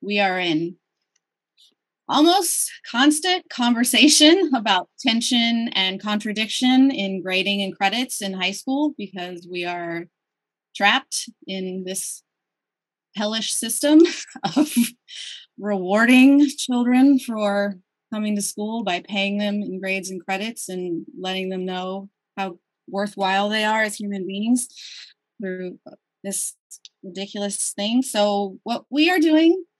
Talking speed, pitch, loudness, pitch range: 120 wpm, 205 Hz, -20 LUFS, 190-250 Hz